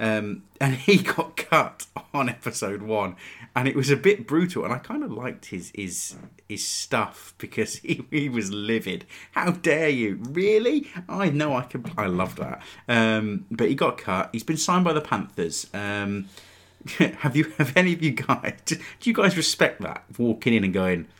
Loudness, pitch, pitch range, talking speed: -24 LUFS, 140 Hz, 110-165 Hz, 190 wpm